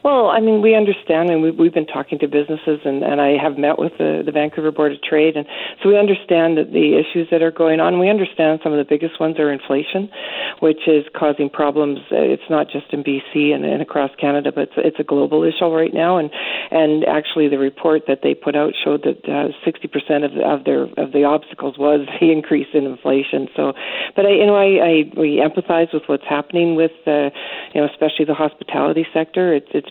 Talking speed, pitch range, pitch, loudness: 225 wpm, 145-165 Hz, 155 Hz, -17 LUFS